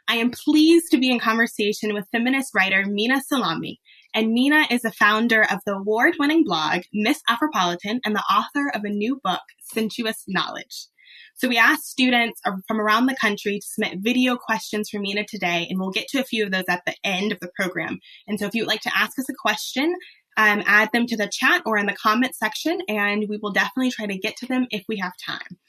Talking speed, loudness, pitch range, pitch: 225 wpm, -21 LUFS, 205-255 Hz, 220 Hz